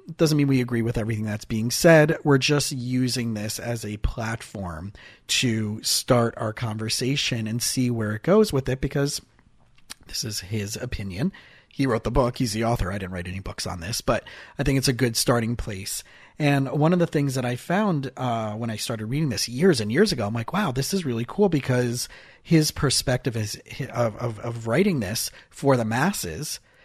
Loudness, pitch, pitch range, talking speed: -24 LUFS, 120 Hz, 110-140 Hz, 205 wpm